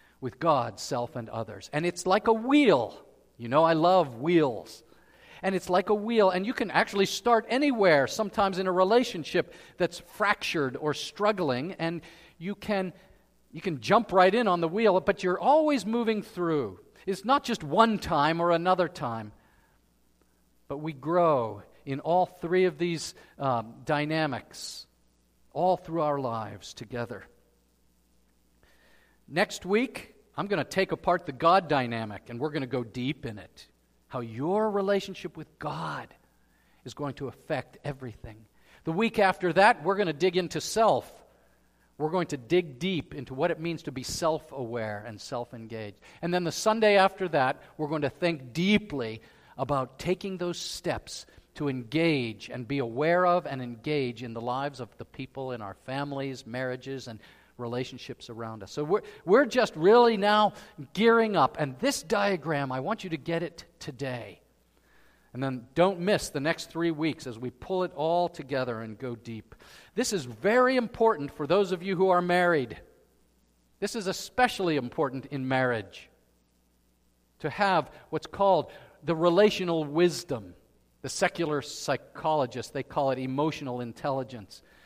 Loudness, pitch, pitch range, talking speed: -28 LUFS, 155 Hz, 125-185 Hz, 165 wpm